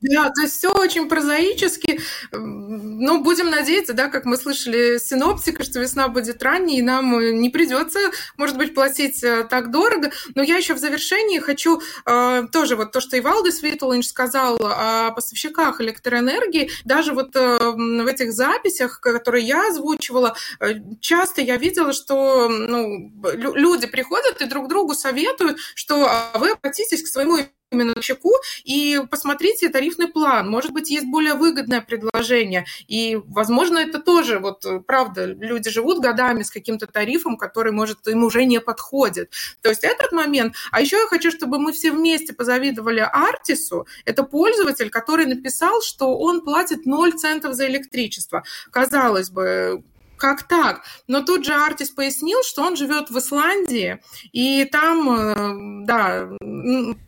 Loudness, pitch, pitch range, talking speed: -19 LUFS, 275 Hz, 235-315 Hz, 150 wpm